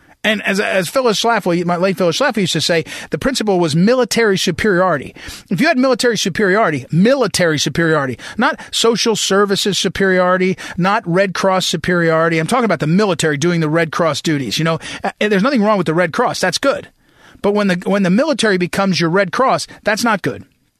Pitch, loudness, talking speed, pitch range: 190 Hz, -15 LUFS, 190 wpm, 170-215 Hz